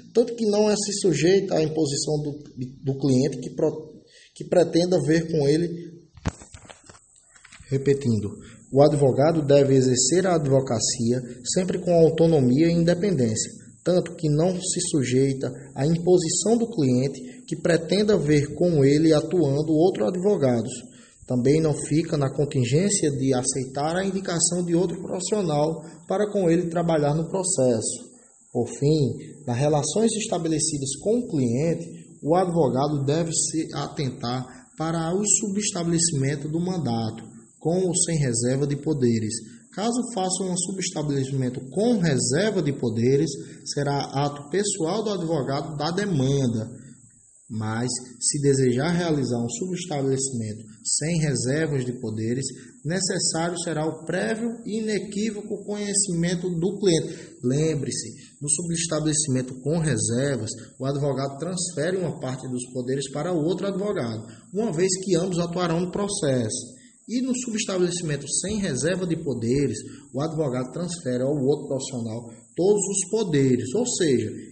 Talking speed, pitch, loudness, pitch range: 130 wpm, 155 Hz, -24 LUFS, 130-180 Hz